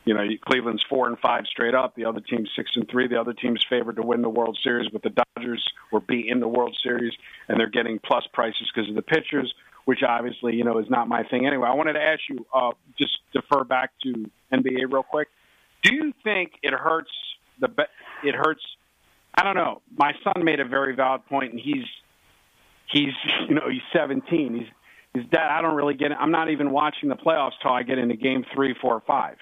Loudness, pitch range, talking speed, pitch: -24 LUFS, 120-145 Hz, 230 wpm, 130 Hz